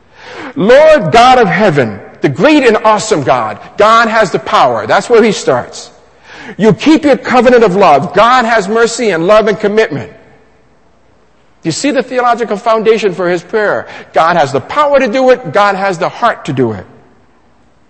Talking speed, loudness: 175 wpm, -9 LUFS